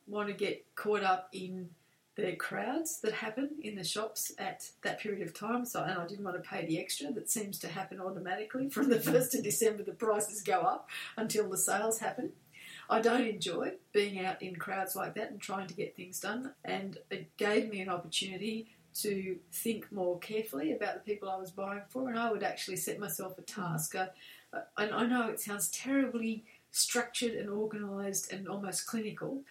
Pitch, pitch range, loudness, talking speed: 205 Hz, 185-220 Hz, -35 LUFS, 200 wpm